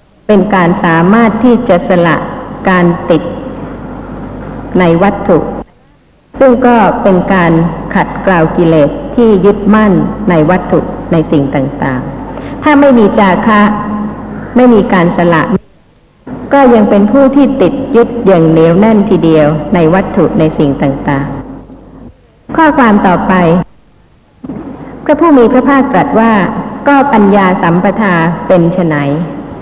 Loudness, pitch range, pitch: -8 LUFS, 170-230 Hz, 195 Hz